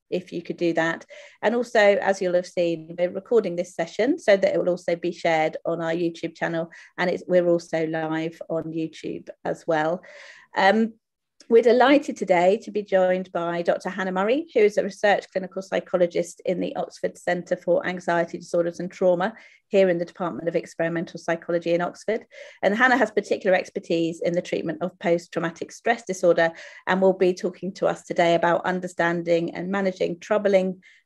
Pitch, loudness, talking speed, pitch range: 180 Hz, -24 LUFS, 185 wpm, 170-195 Hz